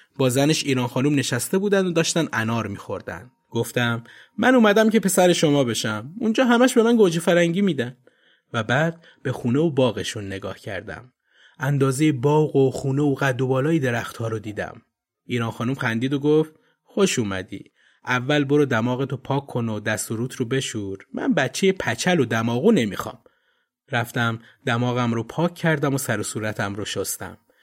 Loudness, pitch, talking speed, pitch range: -22 LUFS, 135 Hz, 170 wpm, 115-160 Hz